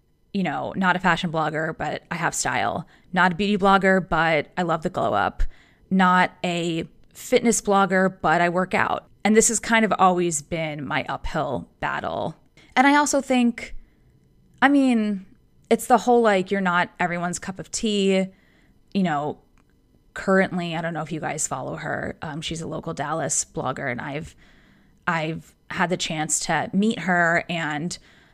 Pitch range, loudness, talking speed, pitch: 165-205 Hz, -22 LUFS, 170 wpm, 180 Hz